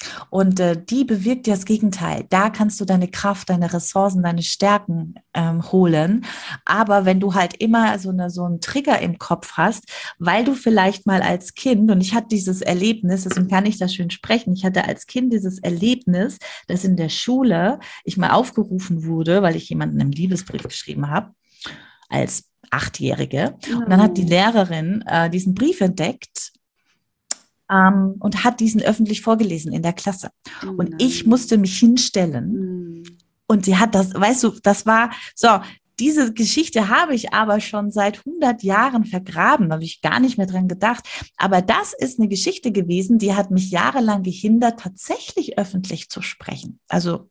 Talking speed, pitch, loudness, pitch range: 175 wpm, 200 Hz, -19 LUFS, 180-225 Hz